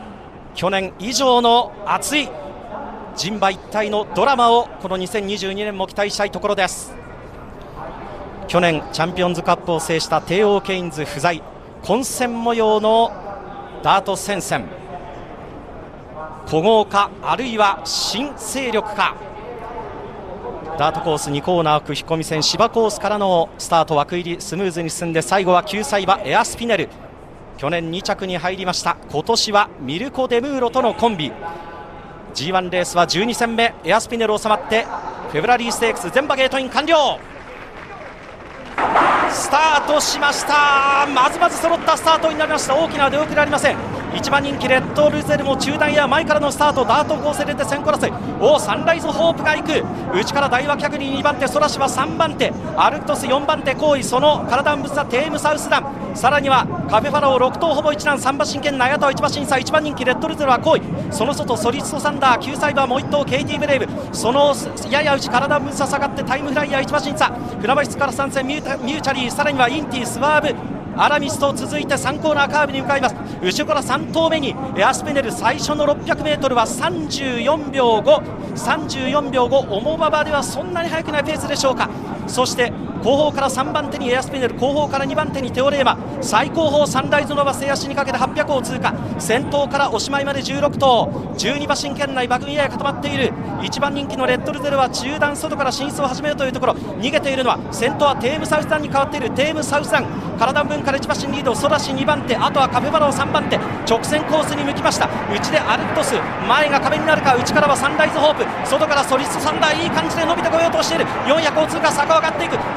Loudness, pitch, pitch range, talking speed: -18 LUFS, 270 Hz, 215-290 Hz, 385 characters per minute